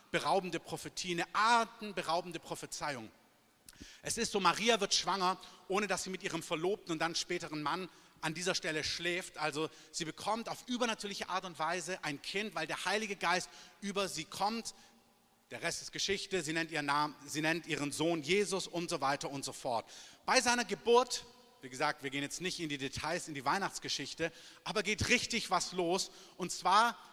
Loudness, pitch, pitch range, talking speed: -35 LUFS, 175 Hz, 160-200 Hz, 185 wpm